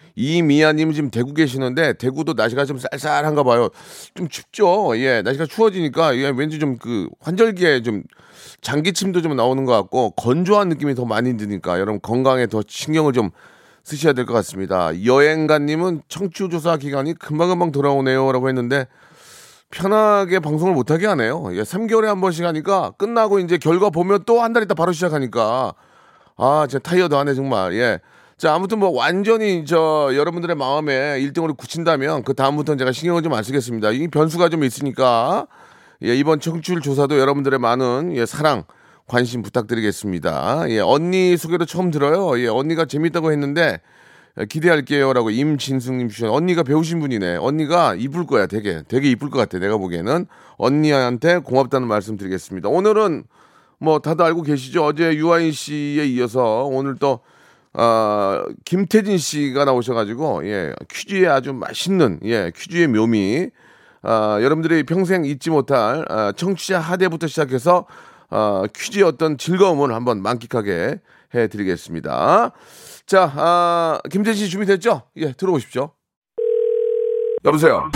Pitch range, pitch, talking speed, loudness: 130-175 Hz, 150 Hz, 350 characters per minute, -18 LUFS